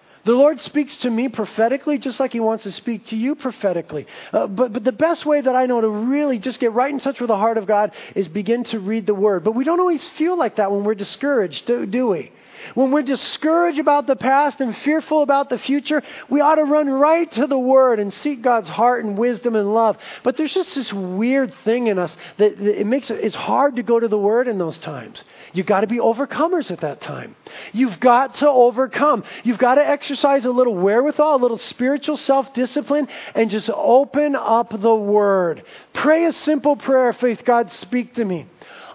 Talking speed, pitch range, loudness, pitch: 220 wpm, 220-285 Hz, -19 LUFS, 250 Hz